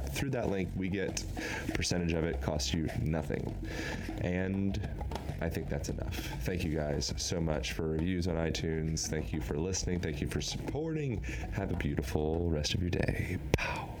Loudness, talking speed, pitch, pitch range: -34 LUFS, 175 wpm, 85 Hz, 80-95 Hz